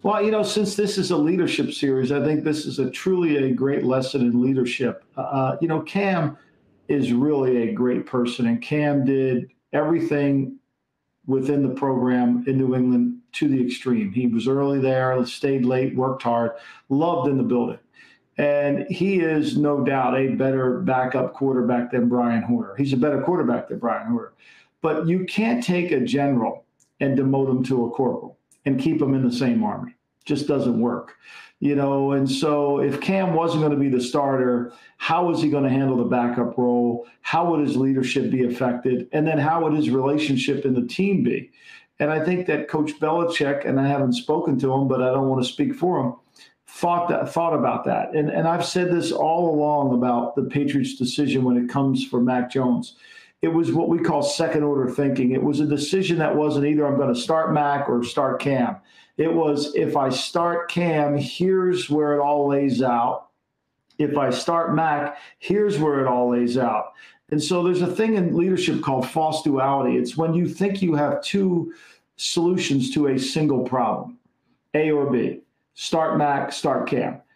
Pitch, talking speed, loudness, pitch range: 140 Hz, 190 wpm, -22 LUFS, 130-165 Hz